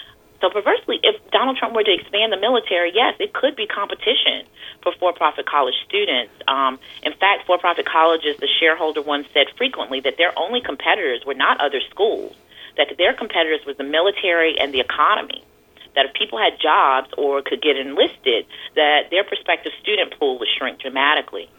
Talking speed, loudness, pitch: 175 wpm, -19 LUFS, 210 Hz